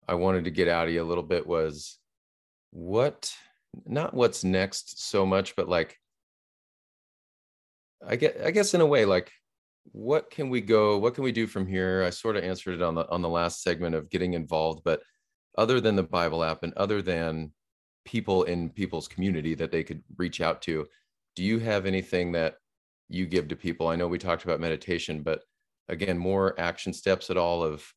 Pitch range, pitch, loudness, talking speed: 85-95 Hz, 90 Hz, -28 LUFS, 200 wpm